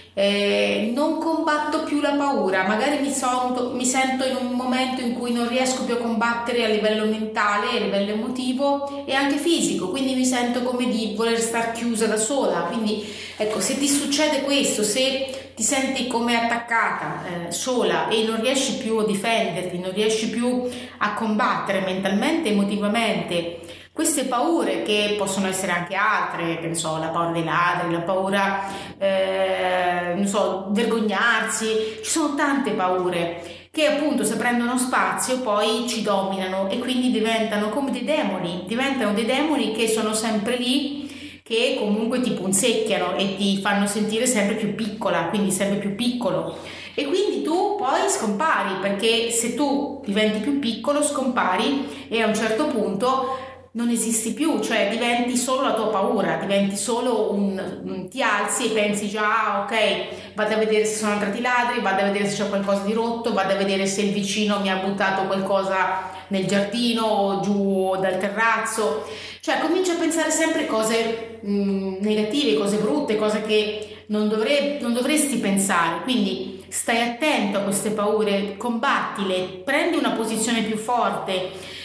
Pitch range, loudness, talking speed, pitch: 200-250 Hz, -22 LUFS, 165 wpm, 220 Hz